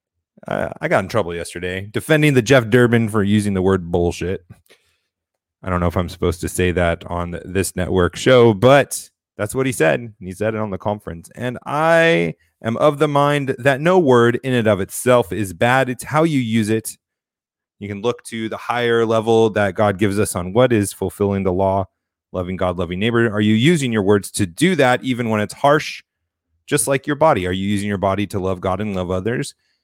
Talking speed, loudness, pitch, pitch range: 215 wpm, -18 LUFS, 105 Hz, 95-125 Hz